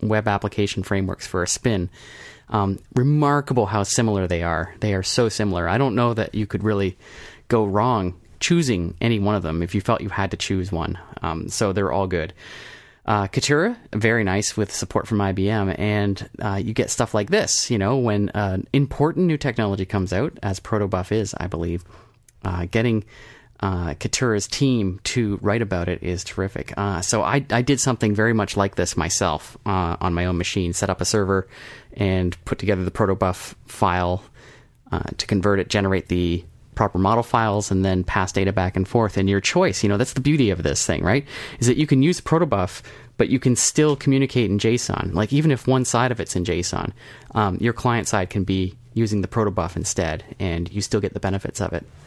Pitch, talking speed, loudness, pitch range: 100 Hz, 205 wpm, -22 LUFS, 95-115 Hz